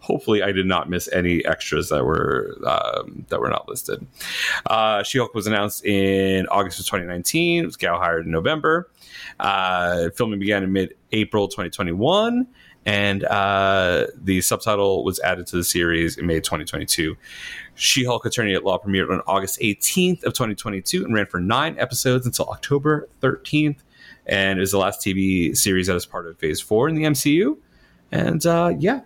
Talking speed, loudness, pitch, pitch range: 190 wpm, -21 LUFS, 100 Hz, 95-125 Hz